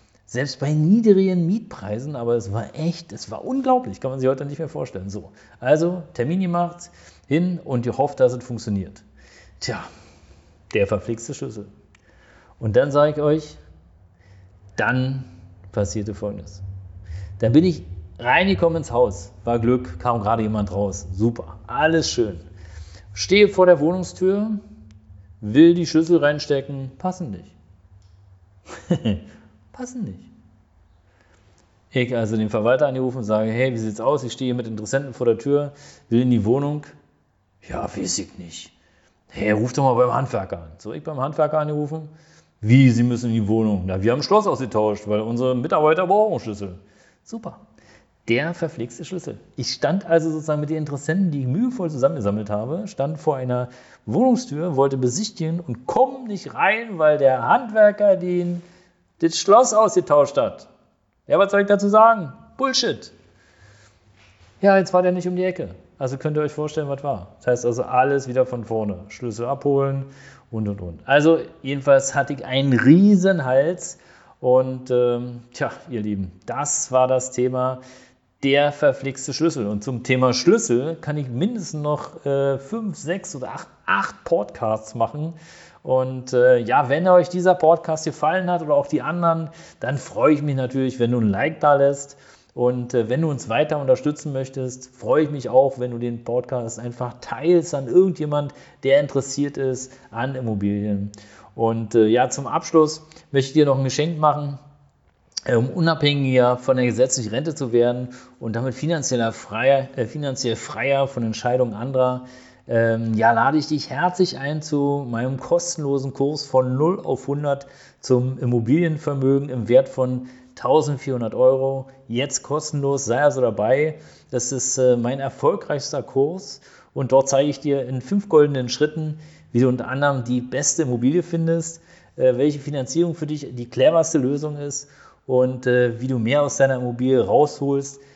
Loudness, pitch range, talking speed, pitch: -21 LUFS, 120-155 Hz, 160 wpm, 135 Hz